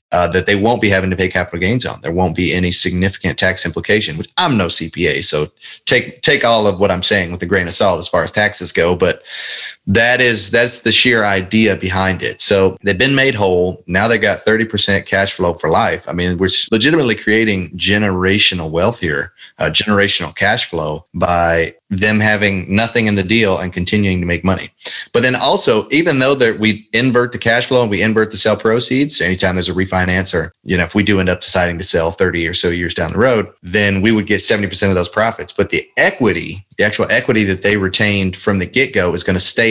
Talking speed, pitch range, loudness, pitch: 230 wpm, 90-110 Hz, -14 LUFS, 95 Hz